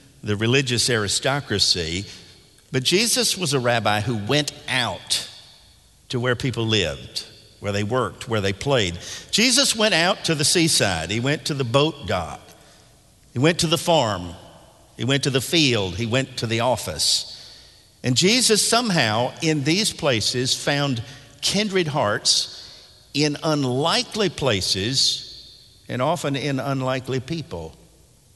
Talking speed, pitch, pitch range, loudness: 140 wpm, 130 Hz, 110-155 Hz, -21 LUFS